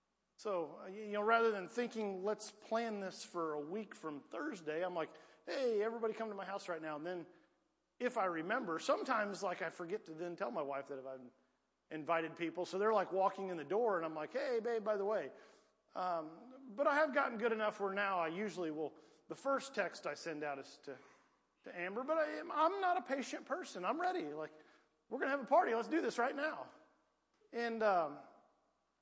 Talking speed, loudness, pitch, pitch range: 210 wpm, -39 LUFS, 205 Hz, 165-235 Hz